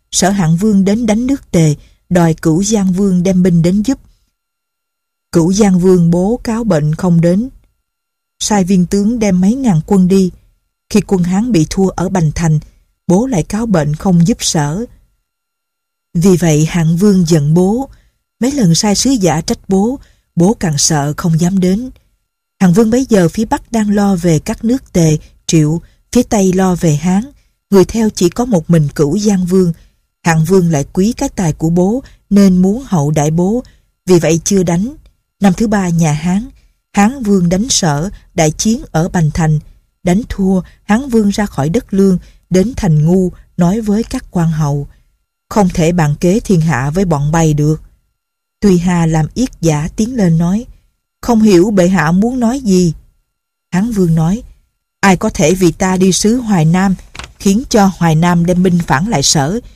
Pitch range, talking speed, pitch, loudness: 170-220 Hz, 185 wpm, 185 Hz, -12 LUFS